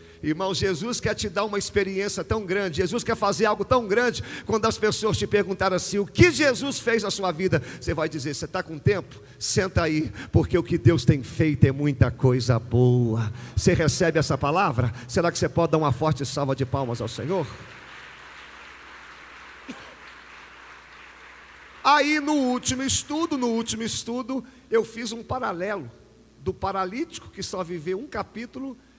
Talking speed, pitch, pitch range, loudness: 170 wpm, 185 Hz, 145-225 Hz, -24 LUFS